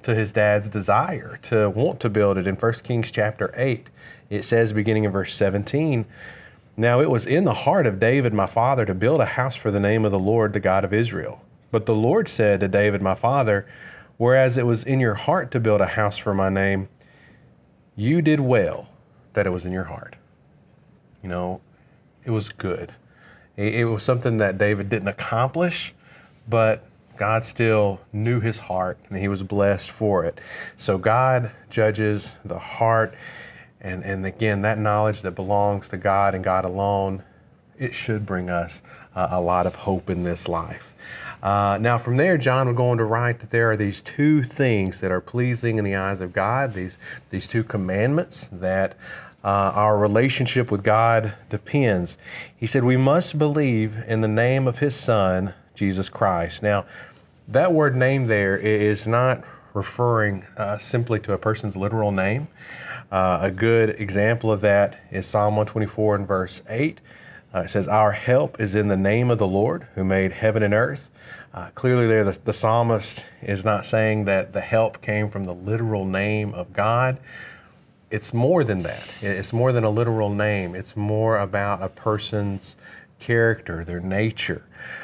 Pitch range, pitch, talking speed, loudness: 100-115 Hz, 105 Hz, 180 wpm, -22 LUFS